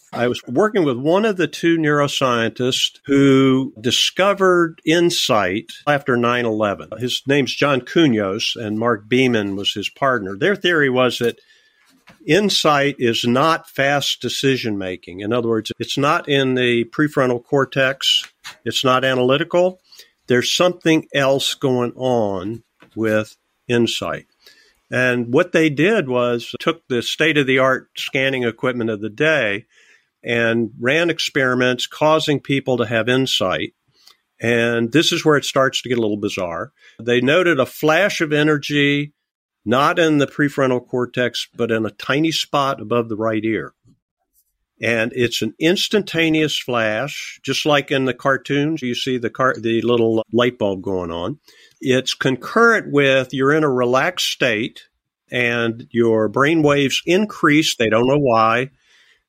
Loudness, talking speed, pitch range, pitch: -18 LUFS, 145 wpm, 120-150 Hz, 130 Hz